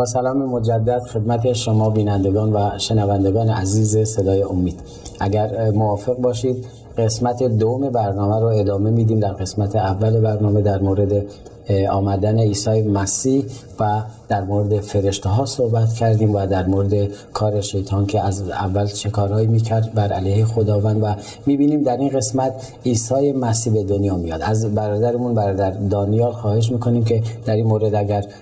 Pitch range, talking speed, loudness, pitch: 100-115 Hz, 150 wpm, -19 LUFS, 110 Hz